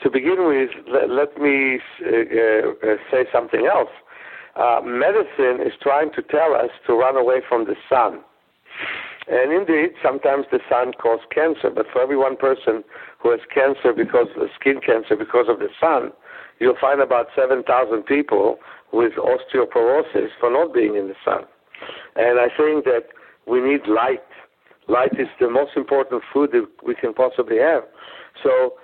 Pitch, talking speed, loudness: 155 Hz, 165 wpm, -19 LUFS